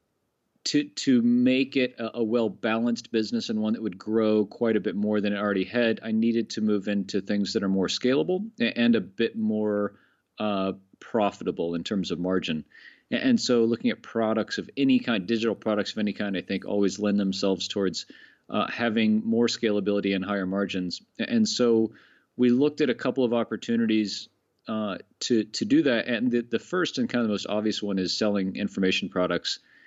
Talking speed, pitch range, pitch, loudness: 195 wpm, 100-120 Hz, 110 Hz, -26 LUFS